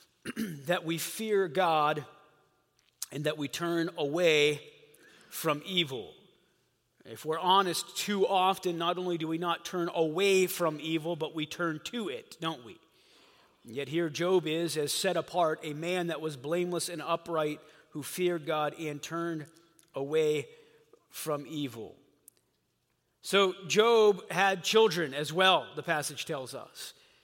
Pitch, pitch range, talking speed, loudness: 170 Hz, 155-185 Hz, 145 wpm, -30 LUFS